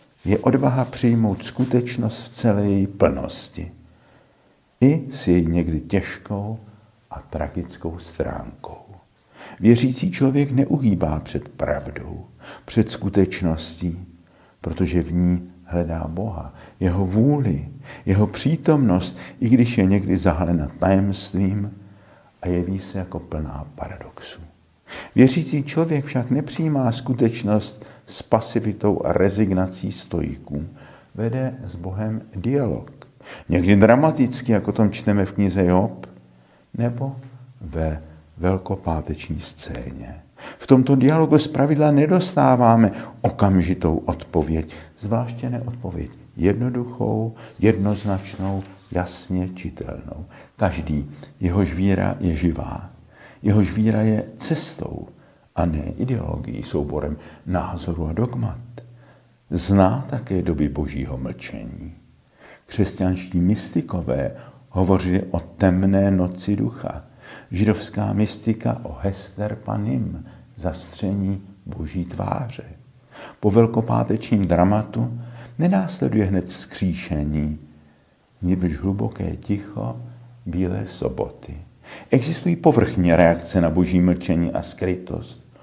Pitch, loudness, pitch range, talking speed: 100 Hz, -21 LUFS, 90-120 Hz, 95 wpm